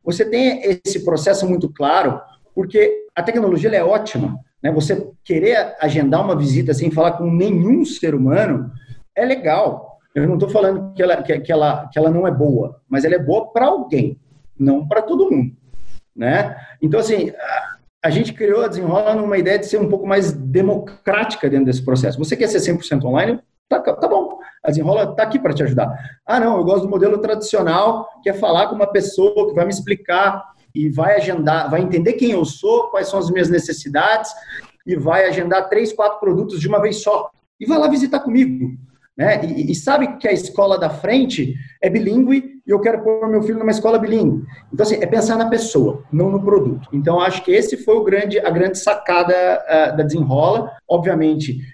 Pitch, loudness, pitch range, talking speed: 190 Hz, -17 LUFS, 155-215 Hz, 200 wpm